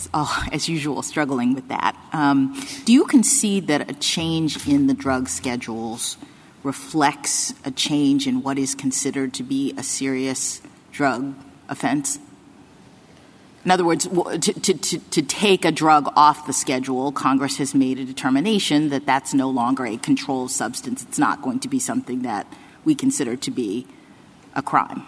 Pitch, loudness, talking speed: 150 Hz, -21 LUFS, 165 wpm